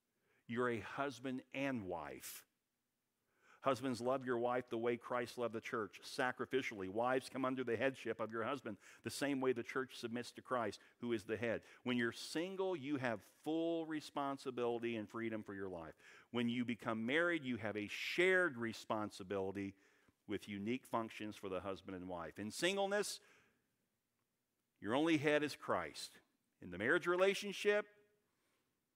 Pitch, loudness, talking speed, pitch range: 125 Hz, -41 LUFS, 155 wpm, 115-140 Hz